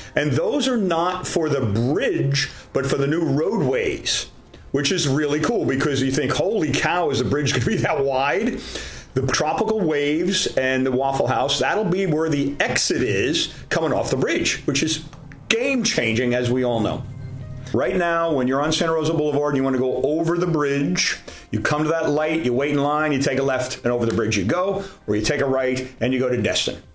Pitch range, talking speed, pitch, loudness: 130-160 Hz, 215 wpm, 145 Hz, -21 LUFS